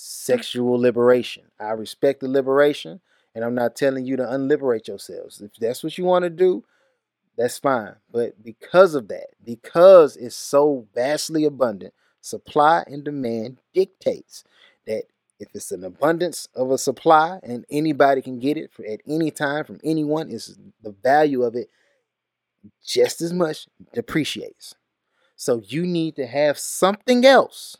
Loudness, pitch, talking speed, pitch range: -20 LUFS, 150 Hz, 155 wpm, 125-175 Hz